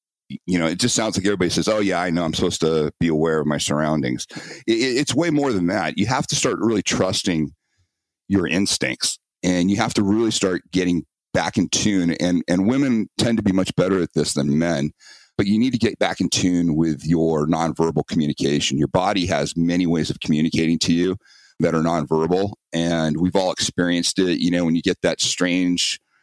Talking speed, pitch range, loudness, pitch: 210 wpm, 80-95 Hz, -20 LUFS, 85 Hz